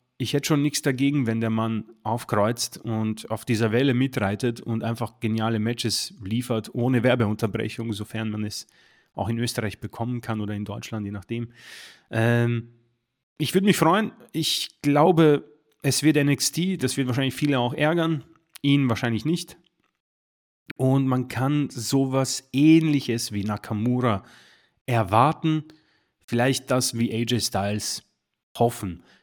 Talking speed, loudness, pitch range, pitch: 140 wpm, -24 LUFS, 110-140 Hz, 120 Hz